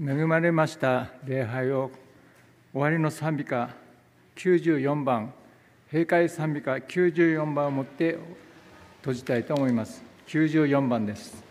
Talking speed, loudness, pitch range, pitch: 205 characters per minute, -26 LUFS, 125-155 Hz, 140 Hz